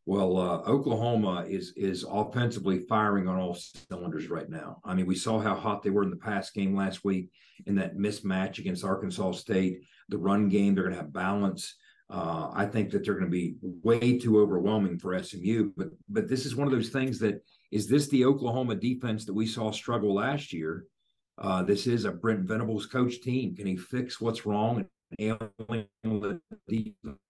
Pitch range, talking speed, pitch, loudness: 95-120 Hz, 190 wpm, 105 Hz, -30 LUFS